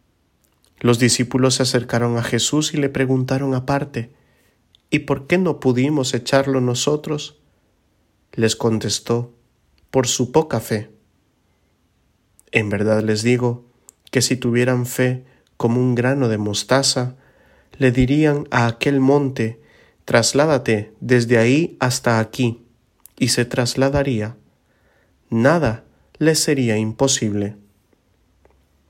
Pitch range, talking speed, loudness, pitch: 110-135 Hz, 110 wpm, -19 LUFS, 125 Hz